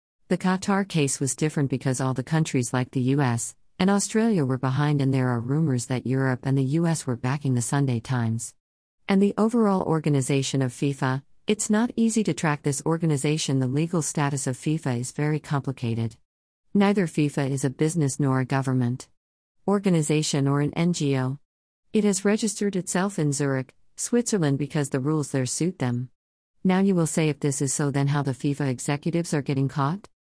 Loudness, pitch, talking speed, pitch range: -25 LUFS, 145 Hz, 180 wpm, 130-165 Hz